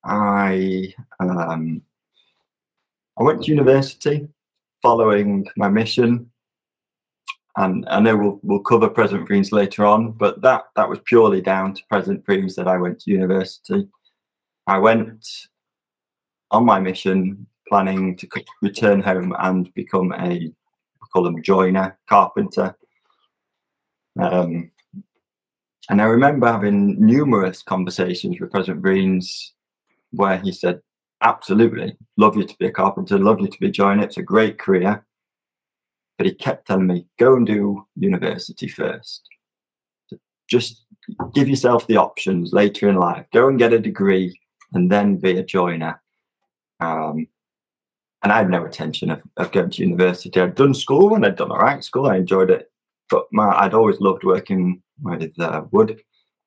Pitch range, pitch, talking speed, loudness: 95-120 Hz, 100 Hz, 150 wpm, -18 LUFS